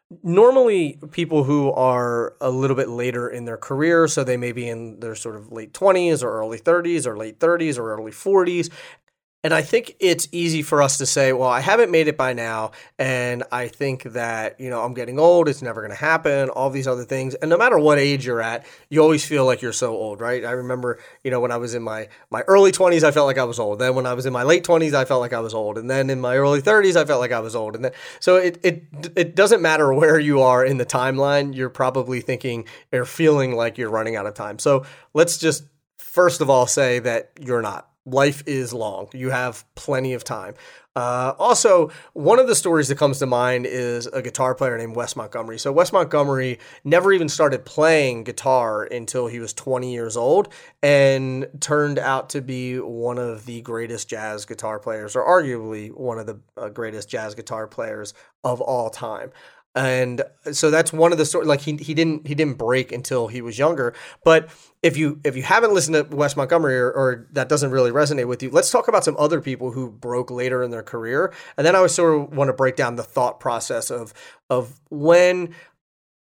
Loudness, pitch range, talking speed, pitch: -20 LUFS, 125-155 Hz, 225 wpm, 130 Hz